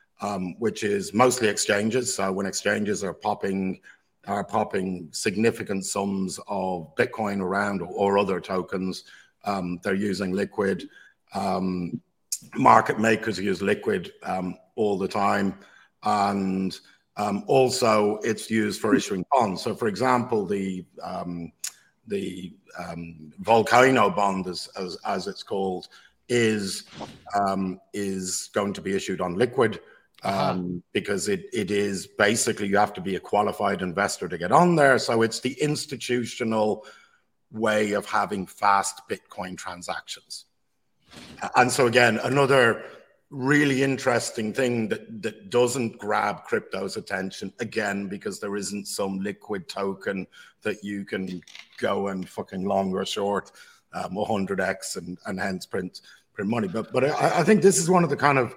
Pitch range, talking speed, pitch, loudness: 95-115 Hz, 145 wpm, 100 Hz, -25 LUFS